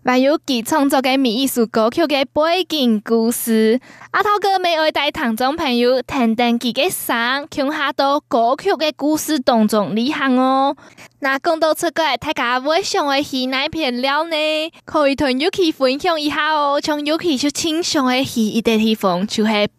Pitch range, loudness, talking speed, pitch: 245-310 Hz, -17 LUFS, 260 characters per minute, 280 Hz